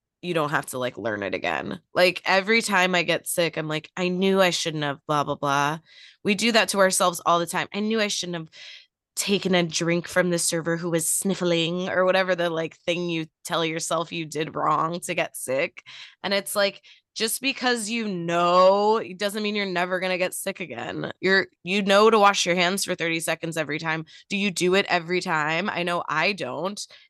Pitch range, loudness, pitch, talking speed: 165-195 Hz, -23 LUFS, 175 Hz, 220 wpm